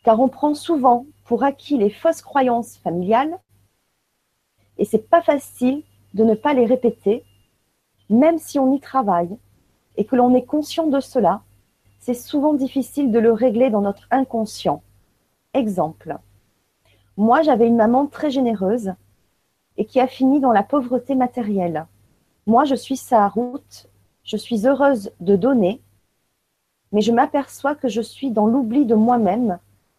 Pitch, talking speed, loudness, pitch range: 240 Hz, 150 wpm, -19 LUFS, 200-270 Hz